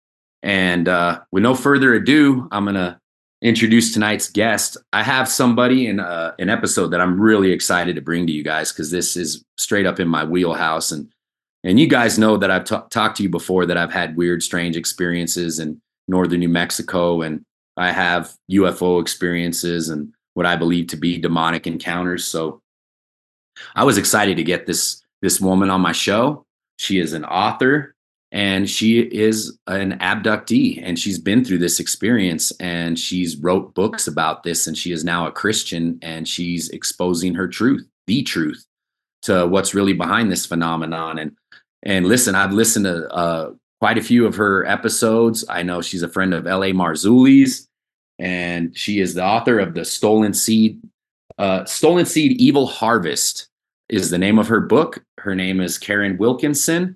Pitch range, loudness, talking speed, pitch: 85-105 Hz, -18 LUFS, 180 wpm, 90 Hz